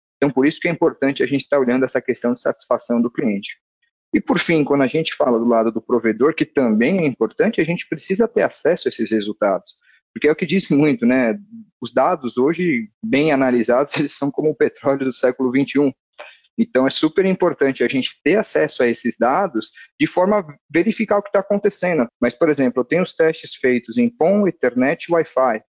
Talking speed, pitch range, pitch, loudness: 210 wpm, 125-175 Hz, 145 Hz, -18 LUFS